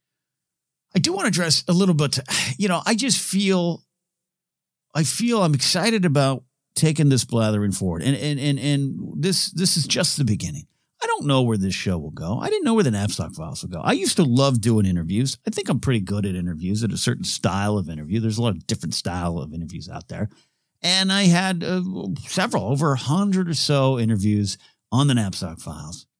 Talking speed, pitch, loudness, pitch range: 215 wpm, 140 Hz, -21 LUFS, 110-180 Hz